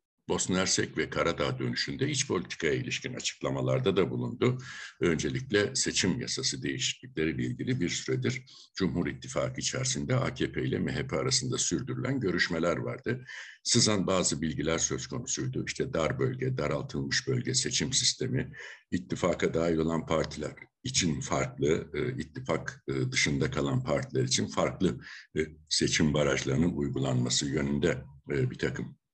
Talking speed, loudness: 120 wpm, -30 LUFS